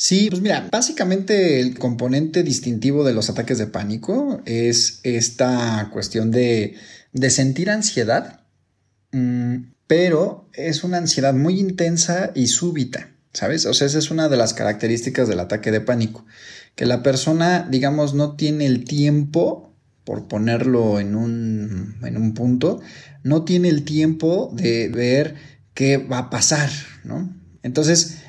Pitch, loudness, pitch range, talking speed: 130 Hz, -19 LUFS, 115-160 Hz, 140 wpm